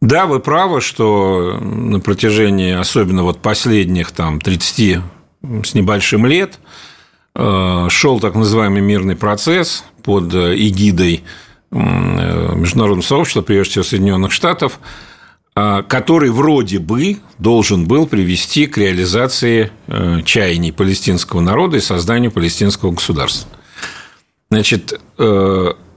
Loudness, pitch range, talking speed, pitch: -13 LUFS, 90-115 Hz, 100 wpm, 100 Hz